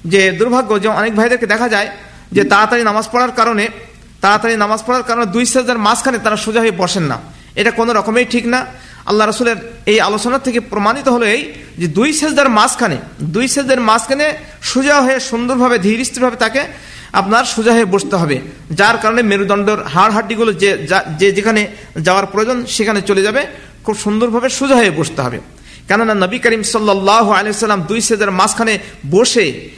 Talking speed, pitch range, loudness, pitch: 150 wpm, 205-240 Hz, -13 LUFS, 220 Hz